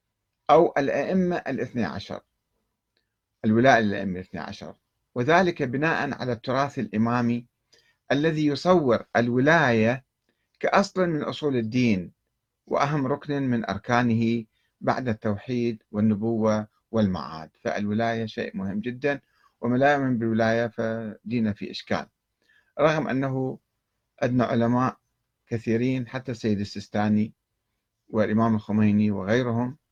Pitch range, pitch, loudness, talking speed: 110-130 Hz, 120 Hz, -25 LUFS, 95 wpm